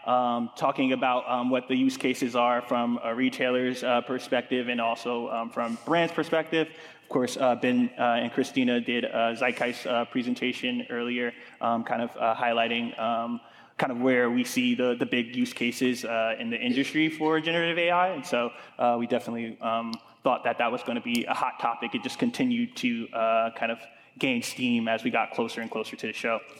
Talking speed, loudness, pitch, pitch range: 200 wpm, -27 LUFS, 125 Hz, 120-155 Hz